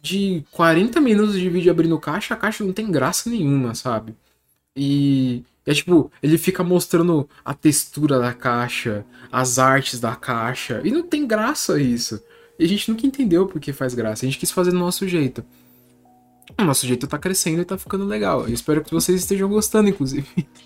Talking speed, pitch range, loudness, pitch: 185 wpm, 125-185 Hz, -20 LUFS, 150 Hz